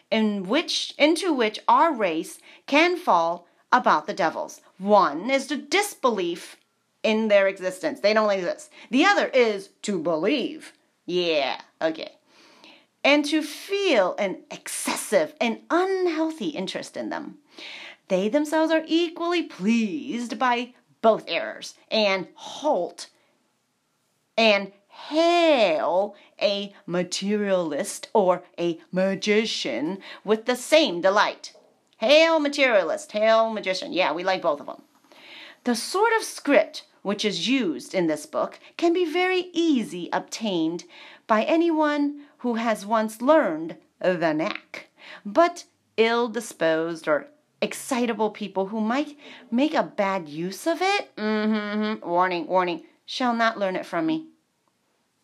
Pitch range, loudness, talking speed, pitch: 205-310 Hz, -24 LUFS, 125 wpm, 270 Hz